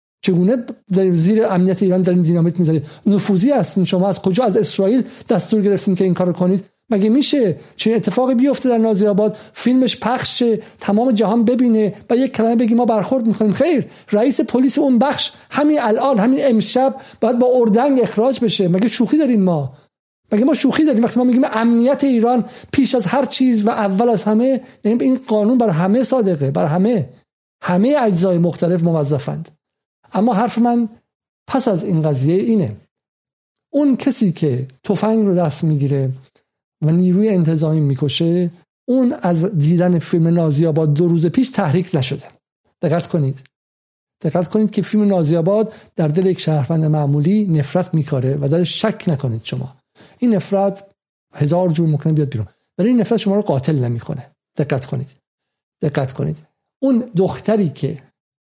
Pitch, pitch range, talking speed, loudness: 195 Hz, 165-235 Hz, 160 wpm, -16 LUFS